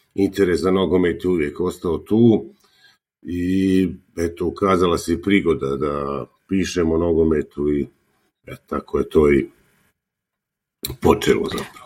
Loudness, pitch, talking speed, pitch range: -20 LUFS, 90 Hz, 120 wpm, 80-95 Hz